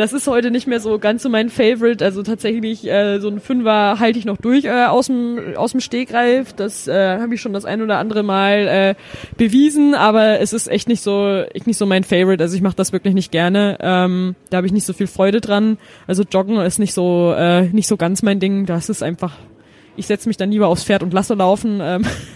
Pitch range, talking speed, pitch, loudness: 190-225 Hz, 235 wpm, 205 Hz, -16 LUFS